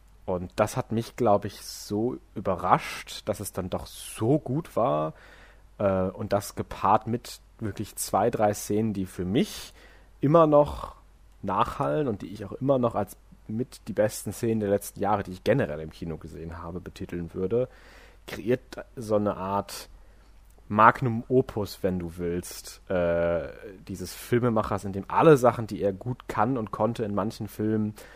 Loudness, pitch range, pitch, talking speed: -27 LUFS, 95-115 Hz, 105 Hz, 165 wpm